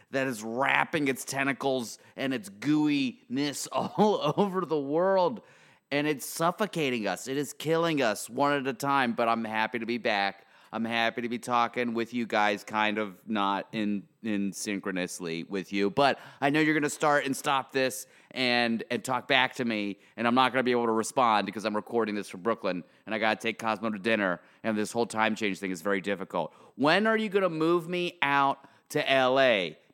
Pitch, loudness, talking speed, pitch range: 125 Hz, -28 LUFS, 210 wpm, 110-145 Hz